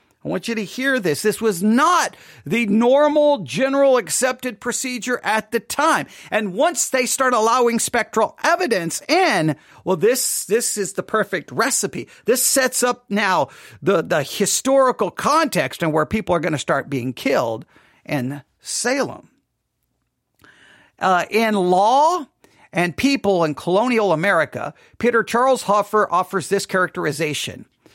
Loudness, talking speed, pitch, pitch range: -19 LUFS, 140 wpm, 220 Hz, 180-255 Hz